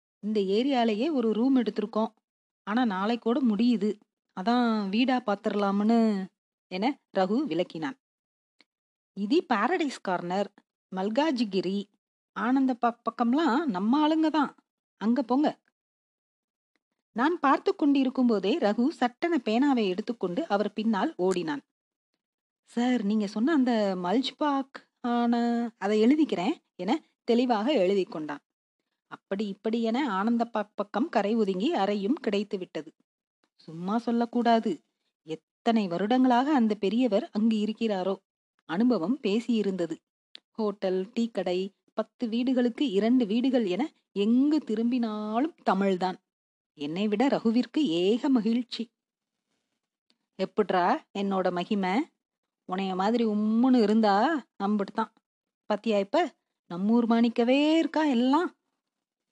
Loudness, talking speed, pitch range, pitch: -27 LUFS, 95 wpm, 205-255 Hz, 230 Hz